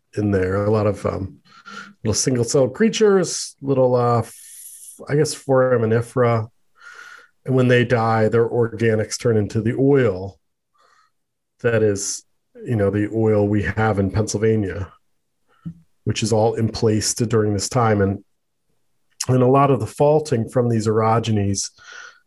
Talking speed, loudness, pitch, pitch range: 145 wpm, -19 LUFS, 115 Hz, 105-130 Hz